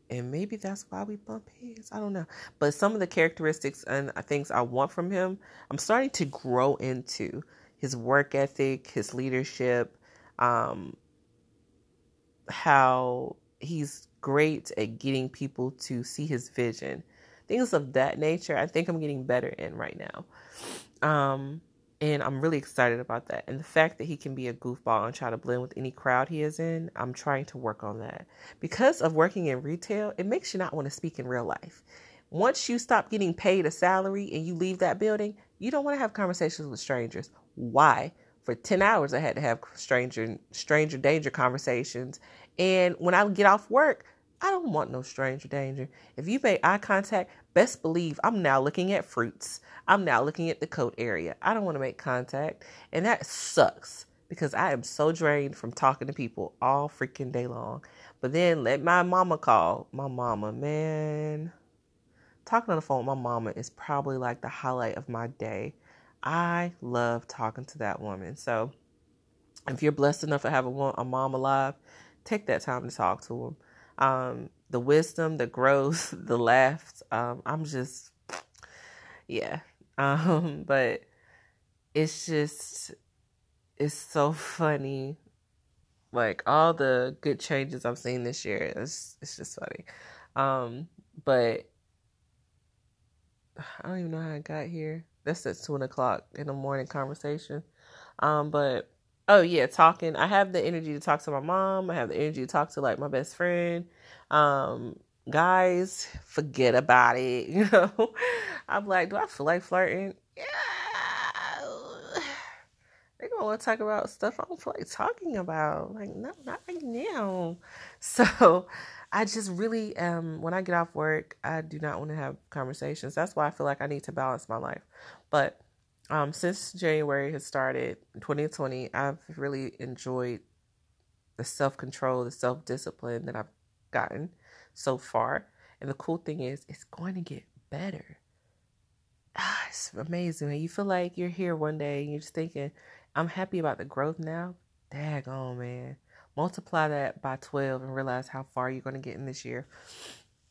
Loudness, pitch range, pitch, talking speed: -29 LUFS, 125-170 Hz, 145 Hz, 175 wpm